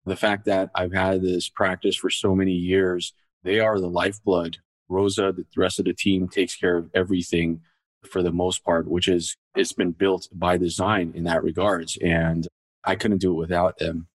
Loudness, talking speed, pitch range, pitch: -23 LUFS, 195 wpm, 85-95 Hz, 90 Hz